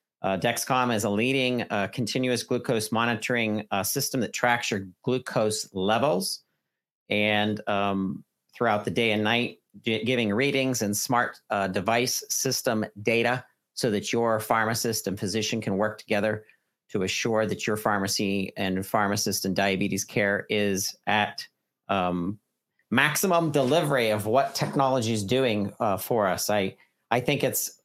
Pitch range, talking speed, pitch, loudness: 100-120 Hz, 145 wpm, 110 Hz, -26 LUFS